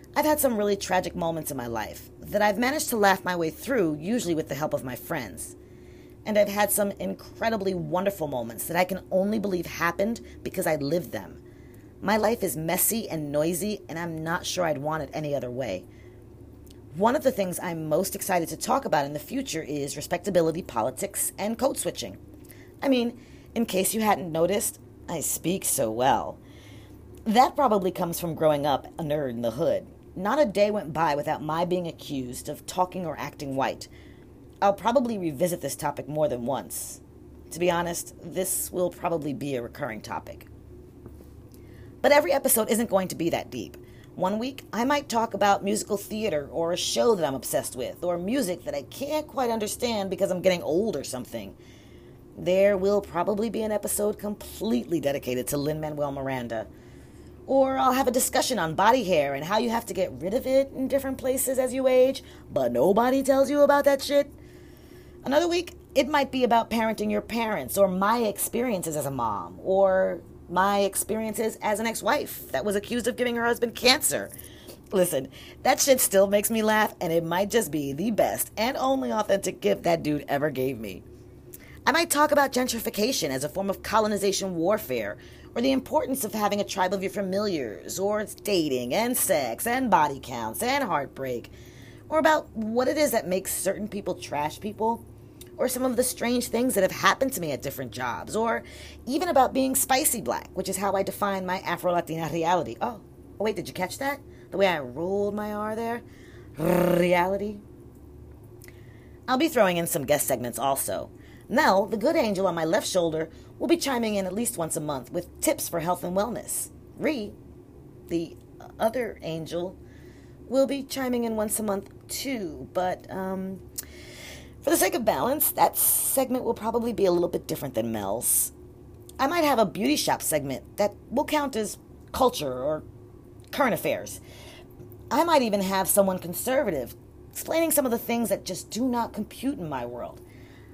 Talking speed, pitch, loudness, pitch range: 190 wpm, 200 Hz, -26 LUFS, 165-235 Hz